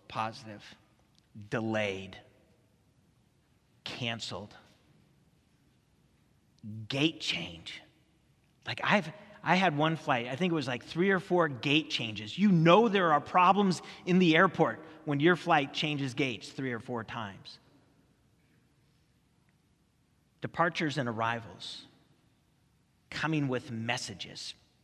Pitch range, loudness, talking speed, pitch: 115-165 Hz, -29 LUFS, 105 wpm, 145 Hz